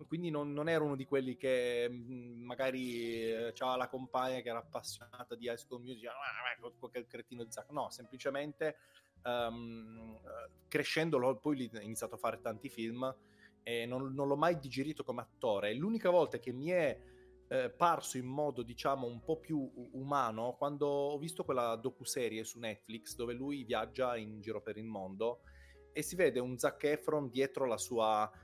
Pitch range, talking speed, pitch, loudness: 115-140 Hz, 170 wpm, 125 Hz, -38 LUFS